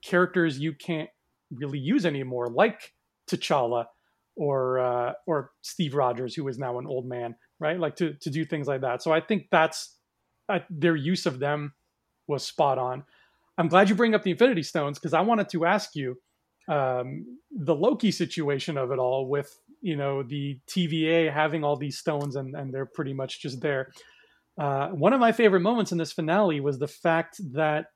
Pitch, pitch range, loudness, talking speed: 155 Hz, 135-170 Hz, -26 LUFS, 190 wpm